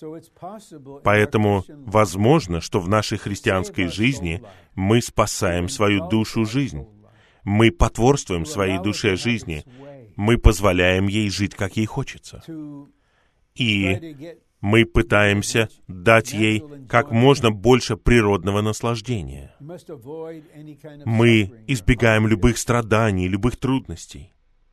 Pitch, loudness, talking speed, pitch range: 110 Hz, -20 LUFS, 95 wpm, 100-125 Hz